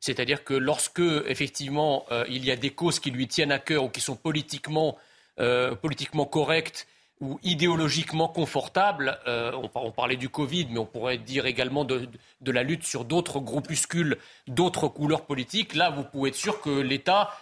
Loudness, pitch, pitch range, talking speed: -27 LUFS, 145 Hz, 130-160 Hz, 180 wpm